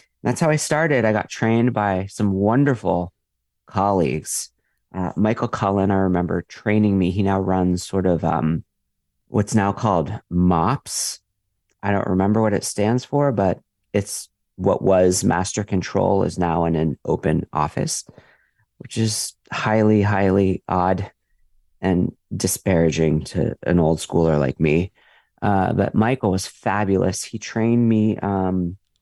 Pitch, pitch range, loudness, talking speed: 95 Hz, 90-110 Hz, -20 LUFS, 145 wpm